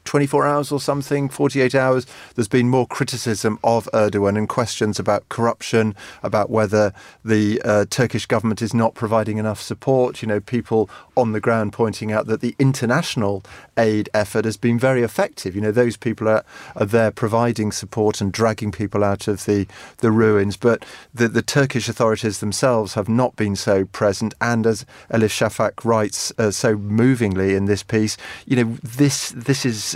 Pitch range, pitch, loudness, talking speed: 105-125 Hz, 115 Hz, -20 LUFS, 175 wpm